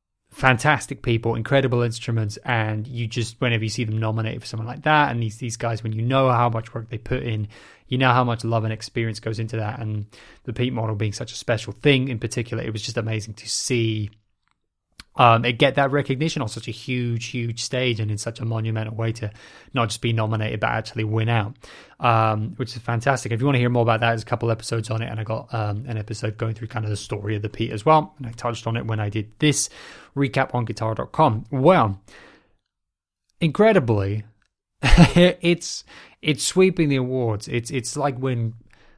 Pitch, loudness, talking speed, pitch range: 115 Hz, -22 LUFS, 215 wpm, 110-125 Hz